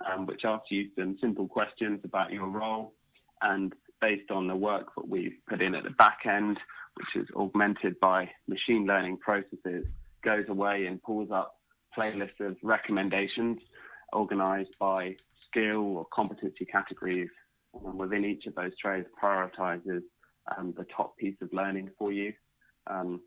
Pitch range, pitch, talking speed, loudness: 95-105 Hz, 100 Hz, 155 wpm, -31 LUFS